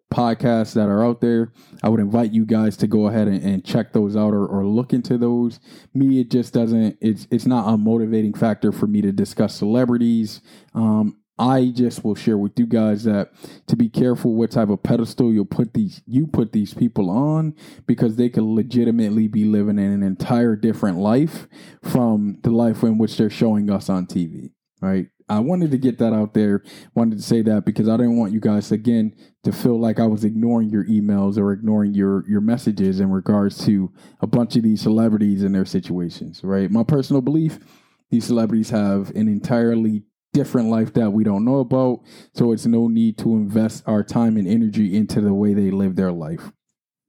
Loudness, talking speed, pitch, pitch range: -19 LUFS, 205 wpm, 110 Hz, 105-120 Hz